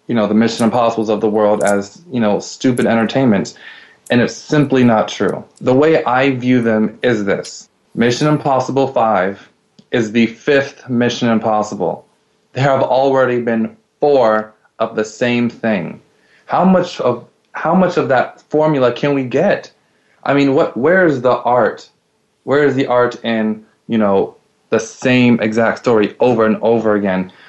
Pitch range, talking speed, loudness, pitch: 110-130 Hz, 165 wpm, -15 LUFS, 120 Hz